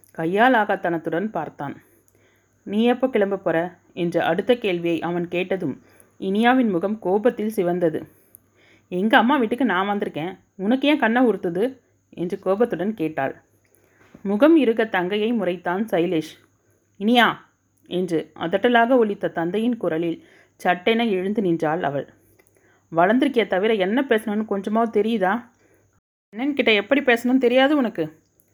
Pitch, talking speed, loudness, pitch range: 195 Hz, 115 wpm, -21 LUFS, 170-230 Hz